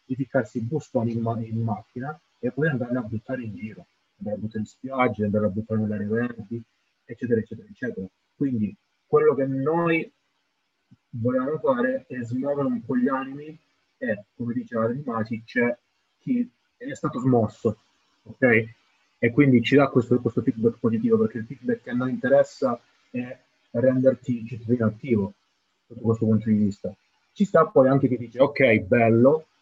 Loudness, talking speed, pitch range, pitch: -24 LUFS, 160 wpm, 115-140 Hz, 125 Hz